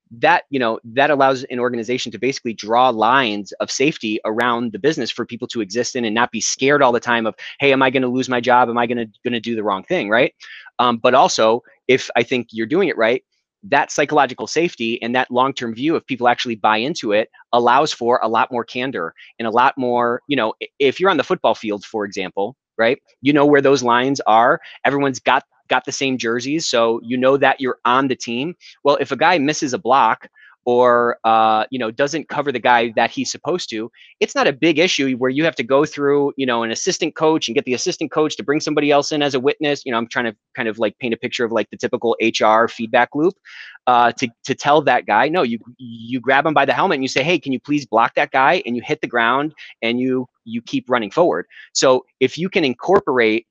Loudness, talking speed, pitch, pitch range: -18 LUFS, 240 wpm, 125 Hz, 115-140 Hz